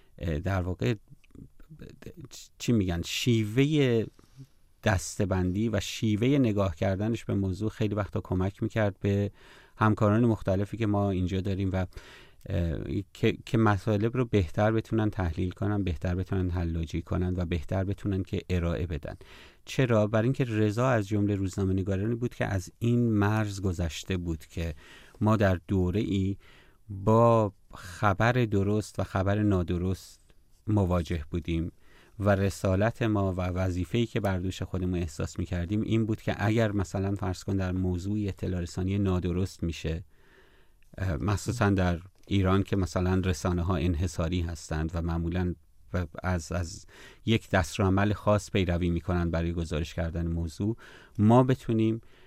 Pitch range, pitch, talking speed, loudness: 90-110 Hz, 95 Hz, 135 wpm, -29 LUFS